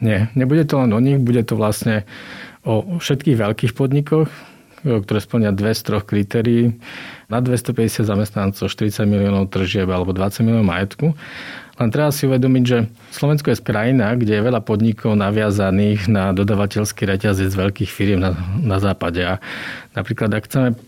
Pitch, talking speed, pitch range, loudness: 110 Hz, 160 wpm, 100-125 Hz, -18 LUFS